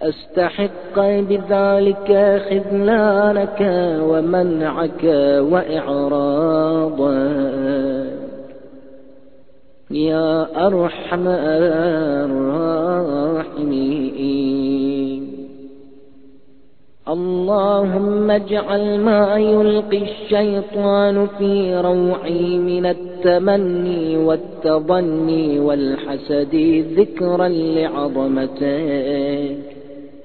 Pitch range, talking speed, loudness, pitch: 140-195 Hz, 40 wpm, -17 LUFS, 160 Hz